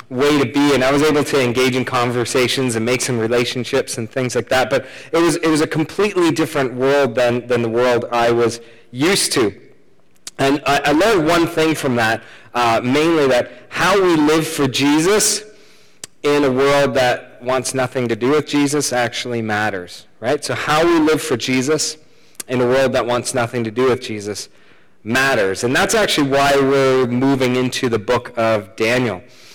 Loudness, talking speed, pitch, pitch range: -17 LUFS, 190 wpm, 130 Hz, 120-150 Hz